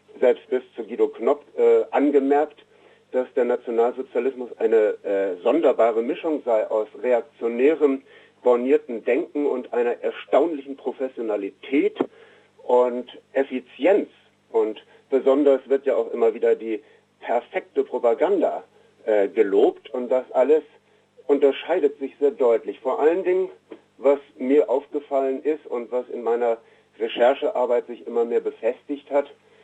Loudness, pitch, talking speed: -22 LUFS, 155 Hz, 125 wpm